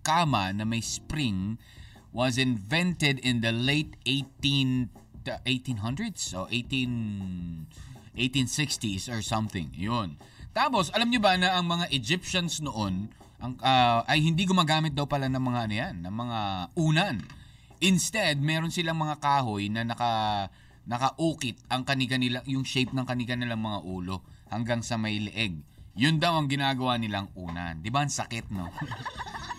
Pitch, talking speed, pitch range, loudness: 125 Hz, 150 wpm, 110-140 Hz, -28 LUFS